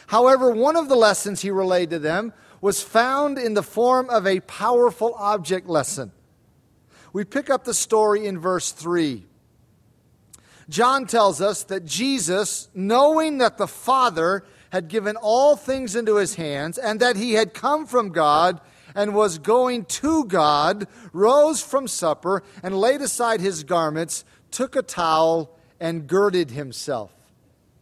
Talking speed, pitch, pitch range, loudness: 150 wpm, 200 Hz, 165-240 Hz, -21 LUFS